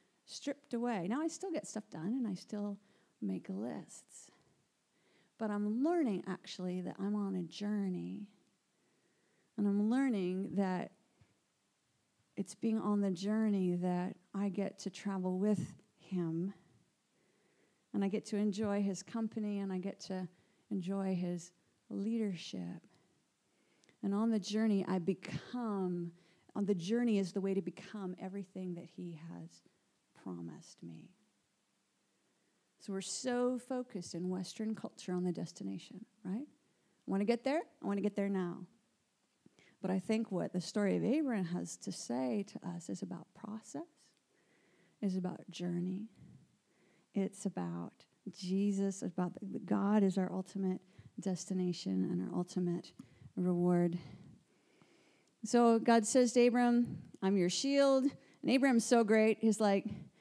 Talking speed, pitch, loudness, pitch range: 140 wpm, 195 Hz, -37 LUFS, 180-220 Hz